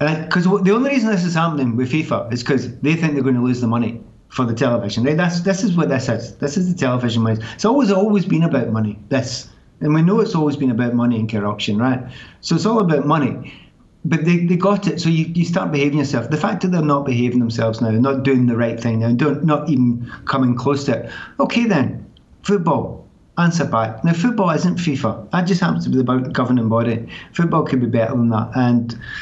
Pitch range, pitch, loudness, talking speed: 120-170 Hz, 135 Hz, -18 LUFS, 235 wpm